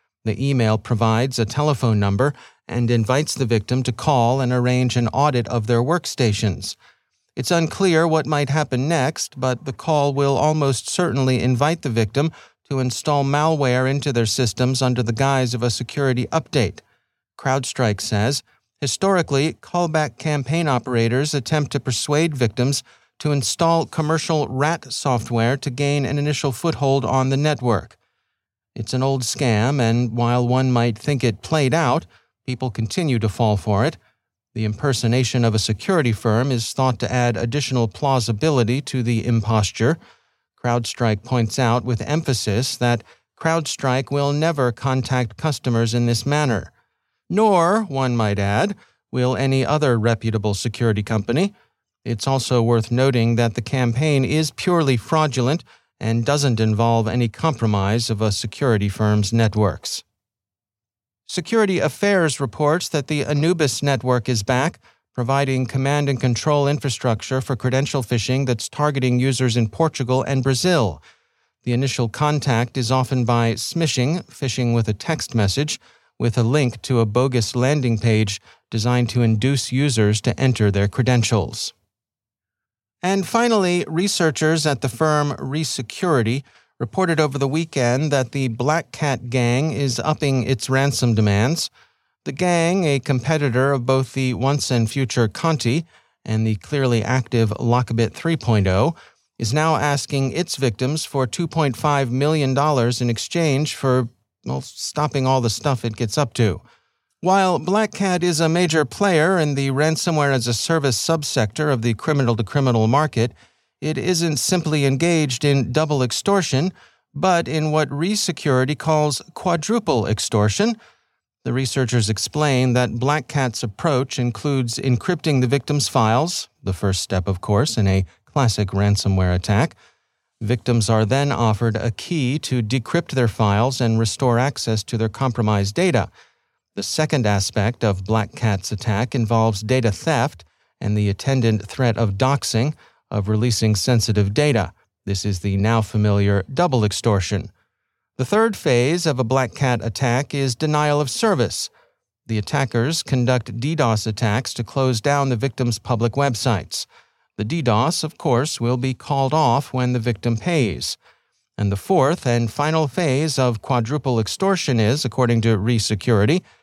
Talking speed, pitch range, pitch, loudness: 145 wpm, 115-145 Hz, 130 Hz, -20 LUFS